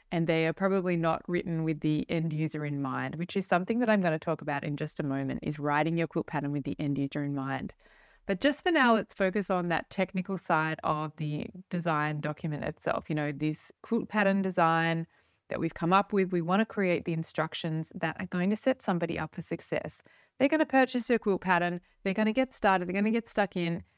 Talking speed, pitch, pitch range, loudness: 240 wpm, 170 Hz, 155-195 Hz, -30 LUFS